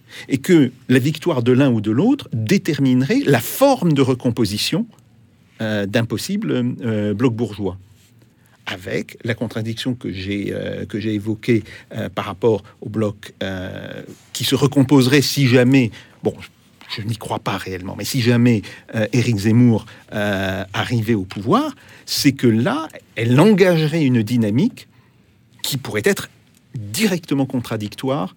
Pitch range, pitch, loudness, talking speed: 110-135 Hz, 120 Hz, -19 LUFS, 145 wpm